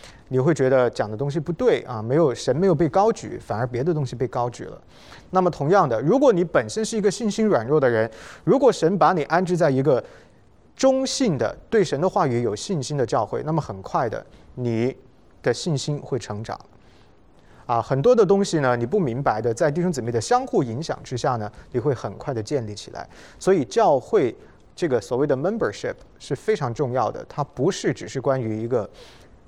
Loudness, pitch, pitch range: -22 LUFS, 140 Hz, 120-180 Hz